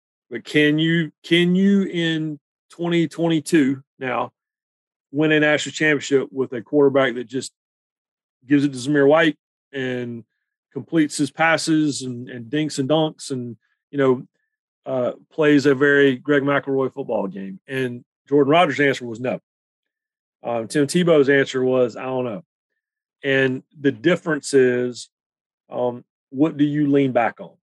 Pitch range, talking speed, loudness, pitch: 130-155 Hz, 145 wpm, -20 LUFS, 140 Hz